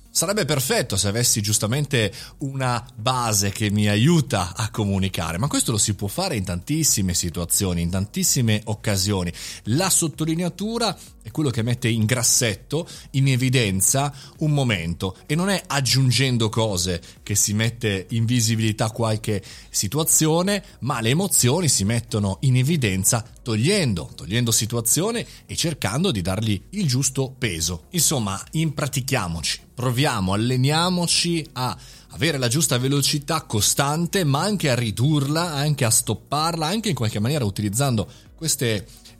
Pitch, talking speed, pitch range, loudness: 120 Hz, 135 wpm, 105-150 Hz, -21 LUFS